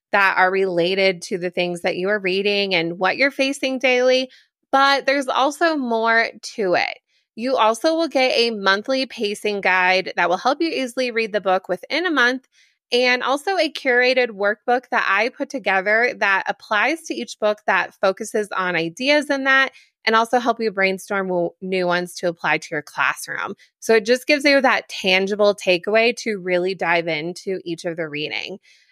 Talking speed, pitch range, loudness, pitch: 185 wpm, 185-260 Hz, -19 LUFS, 215 Hz